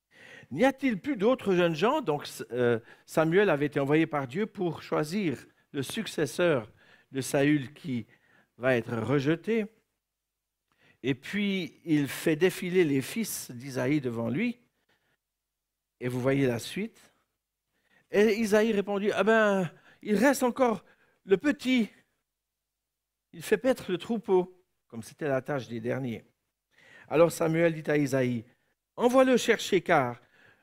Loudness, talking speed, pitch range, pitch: -28 LUFS, 135 wpm, 135-215 Hz, 170 Hz